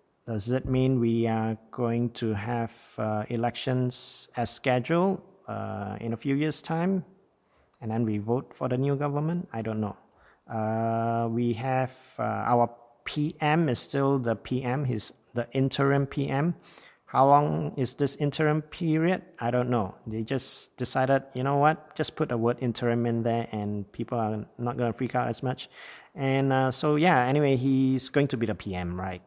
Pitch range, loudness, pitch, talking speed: 115-140 Hz, -28 LUFS, 125 Hz, 175 wpm